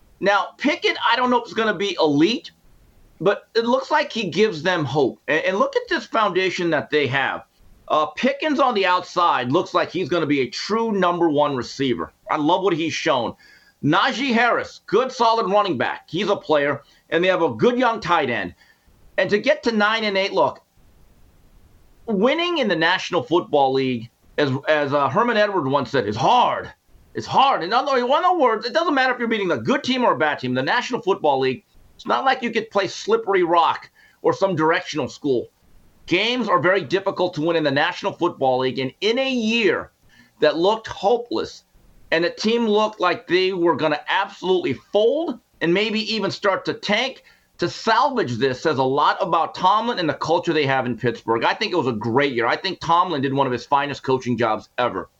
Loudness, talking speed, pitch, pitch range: -20 LUFS, 210 wpm, 180 Hz, 145-230 Hz